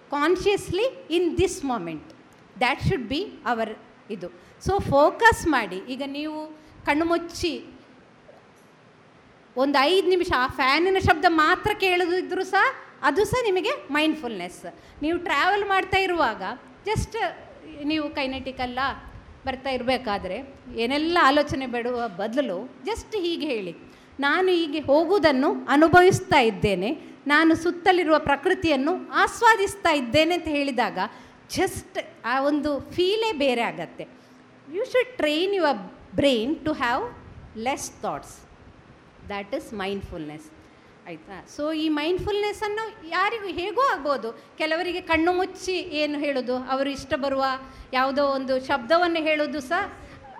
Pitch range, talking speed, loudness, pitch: 265-360 Hz, 115 wpm, -23 LUFS, 305 Hz